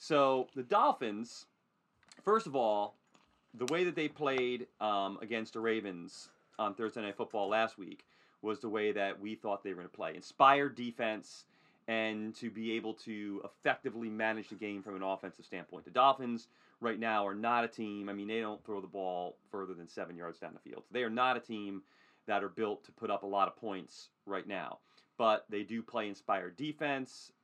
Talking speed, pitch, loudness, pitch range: 205 wpm, 110 Hz, -36 LUFS, 100-120 Hz